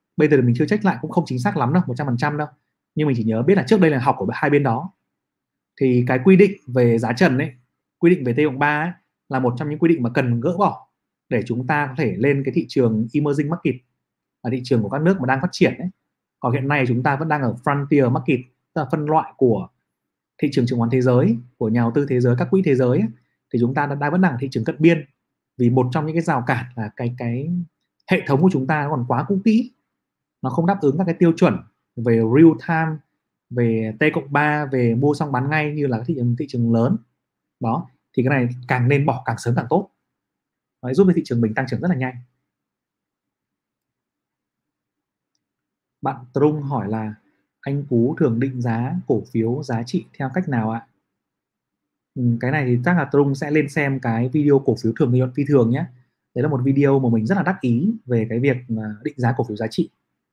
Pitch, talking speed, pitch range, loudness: 135 Hz, 245 wpm, 120-155 Hz, -20 LUFS